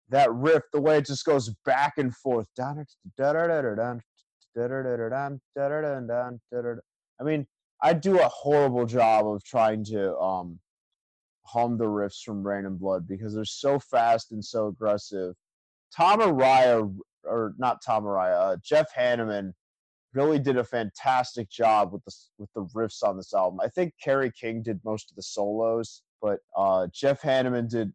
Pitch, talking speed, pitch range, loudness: 120 Hz, 150 wpm, 105-135 Hz, -26 LUFS